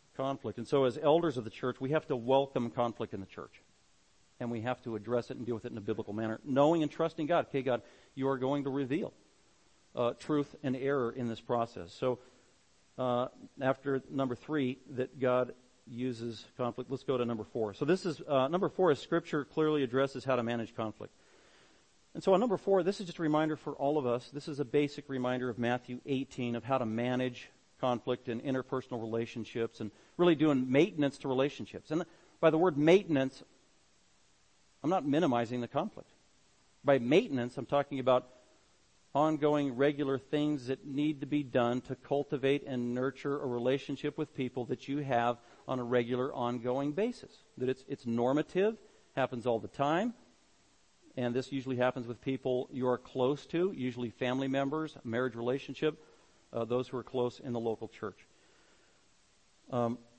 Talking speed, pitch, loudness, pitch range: 180 wpm, 130 Hz, -33 LUFS, 120-145 Hz